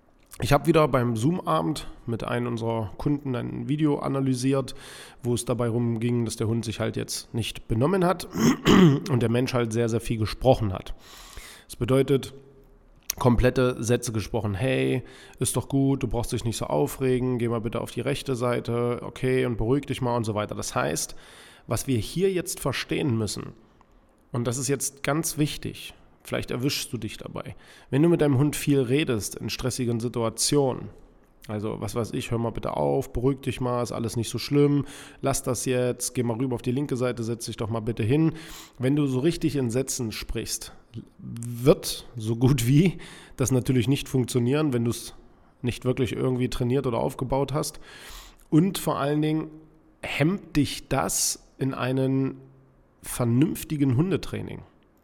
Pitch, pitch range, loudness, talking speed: 125 Hz, 120-140 Hz, -26 LUFS, 175 wpm